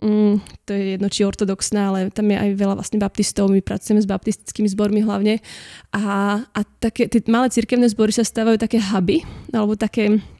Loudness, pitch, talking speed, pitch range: -19 LUFS, 210 Hz, 180 wpm, 200-225 Hz